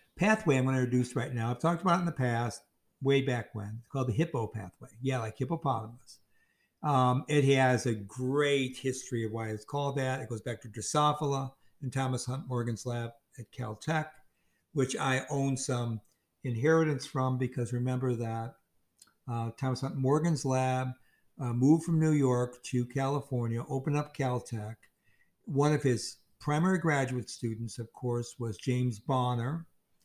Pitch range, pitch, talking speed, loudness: 120-140 Hz, 130 Hz, 165 wpm, -31 LUFS